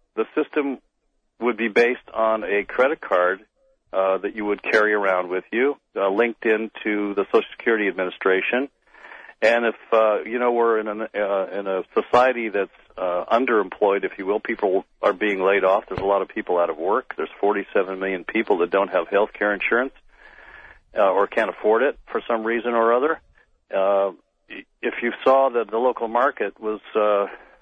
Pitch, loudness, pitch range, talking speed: 110 Hz, -22 LUFS, 100-115 Hz, 185 wpm